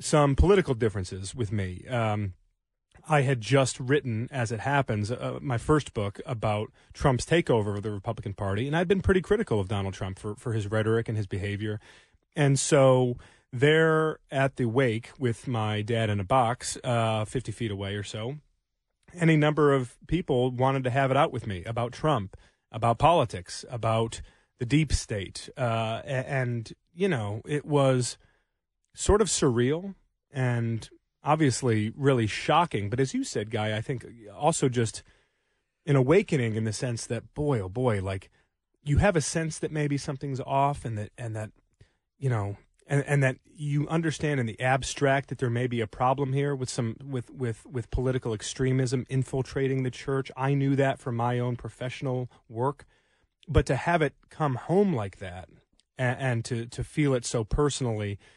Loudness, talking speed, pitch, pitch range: -27 LUFS, 175 wpm, 125 Hz, 110-140 Hz